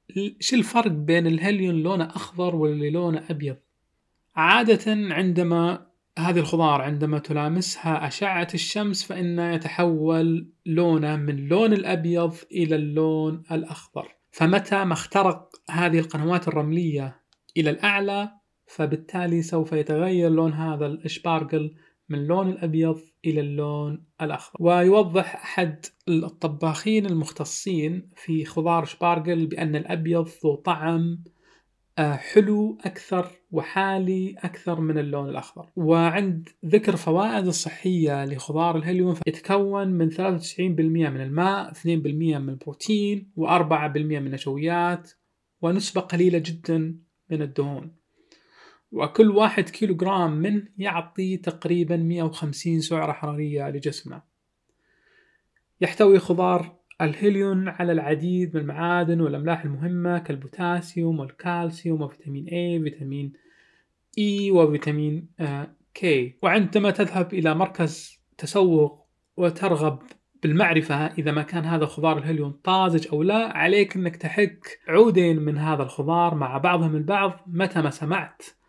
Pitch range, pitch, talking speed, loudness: 155-185 Hz, 170 Hz, 110 wpm, -24 LUFS